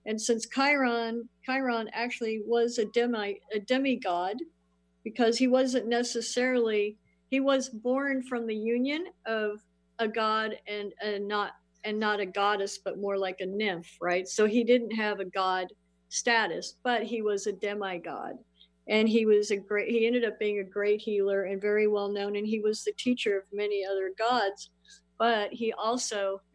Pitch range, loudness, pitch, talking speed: 200-235 Hz, -29 LUFS, 215 Hz, 170 wpm